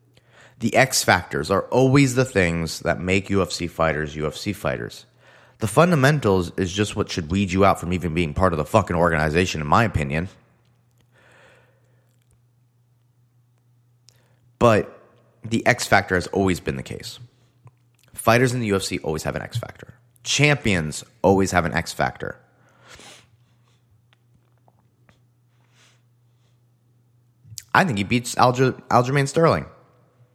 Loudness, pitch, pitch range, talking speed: -21 LUFS, 120 Hz, 95-120 Hz, 125 wpm